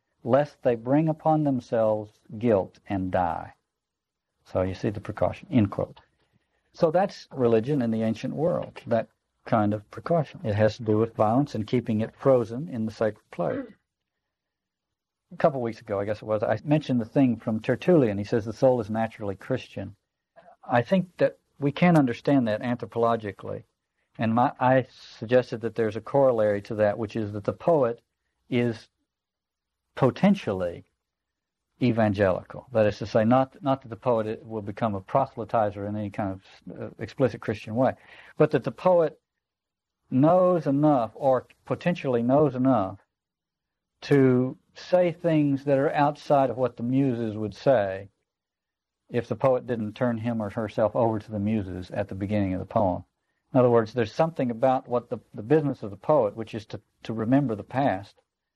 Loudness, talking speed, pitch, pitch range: -25 LUFS, 170 wpm, 115 Hz, 110-135 Hz